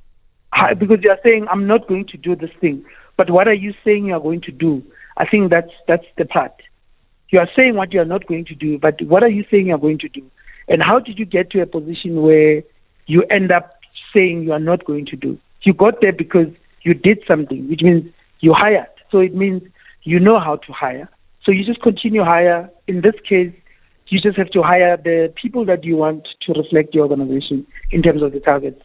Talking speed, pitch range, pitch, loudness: 235 wpm, 160-200 Hz, 175 Hz, -15 LUFS